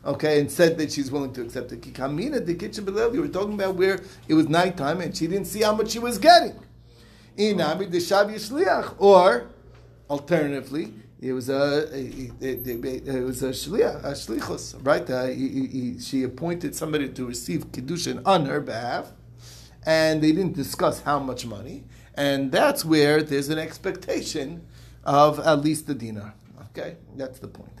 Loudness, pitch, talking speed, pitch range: -23 LUFS, 145 Hz, 160 wpm, 130-170 Hz